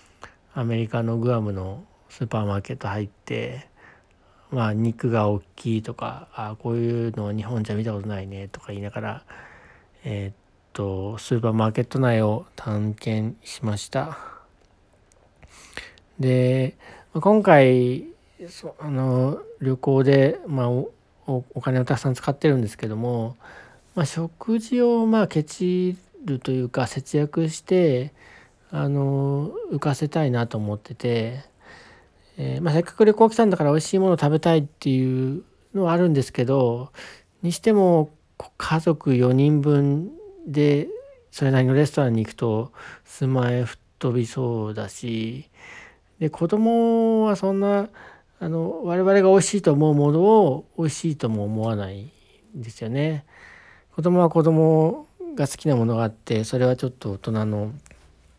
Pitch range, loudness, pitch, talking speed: 110-160 Hz, -22 LUFS, 130 Hz, 285 characters per minute